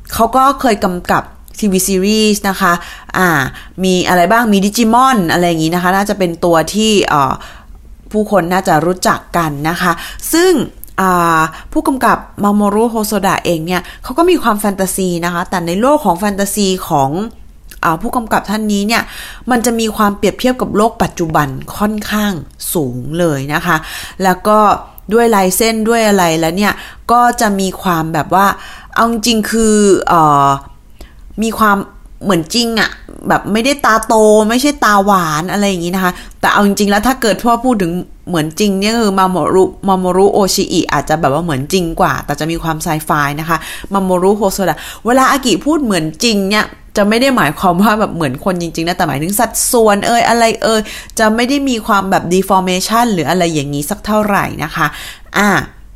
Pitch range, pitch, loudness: 175-220 Hz, 195 Hz, -13 LUFS